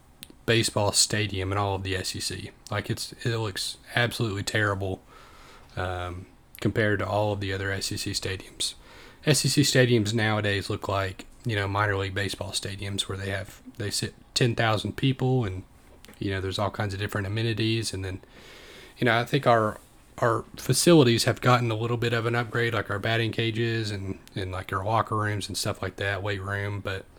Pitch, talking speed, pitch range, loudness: 105 Hz, 185 wpm, 100-115 Hz, -26 LUFS